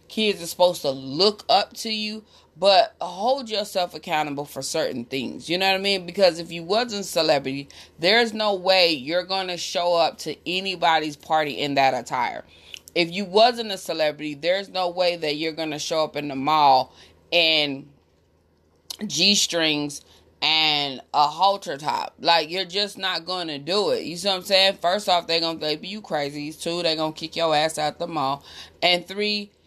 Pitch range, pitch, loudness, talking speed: 150-195 Hz, 170 Hz, -22 LUFS, 195 wpm